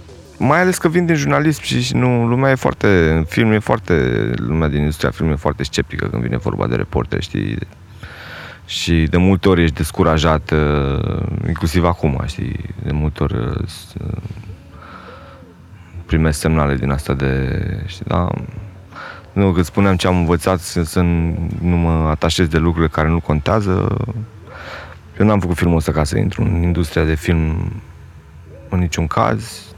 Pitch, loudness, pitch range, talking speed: 85 Hz, -17 LUFS, 80-100 Hz, 155 wpm